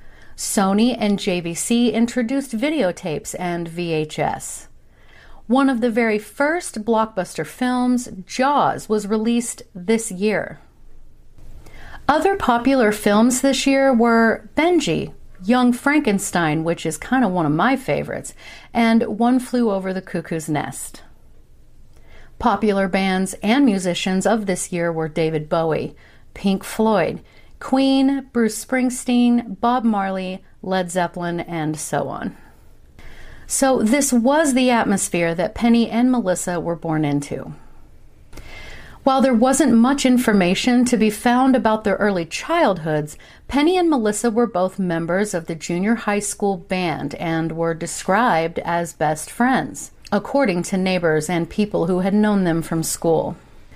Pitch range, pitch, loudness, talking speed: 175-245 Hz, 210 Hz, -19 LUFS, 130 wpm